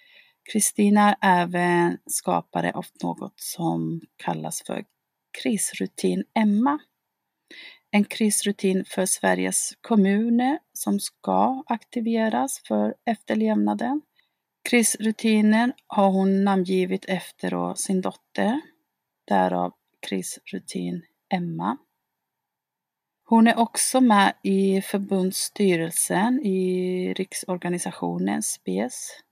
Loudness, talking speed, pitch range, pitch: -23 LUFS, 80 wpm, 175-225 Hz, 195 Hz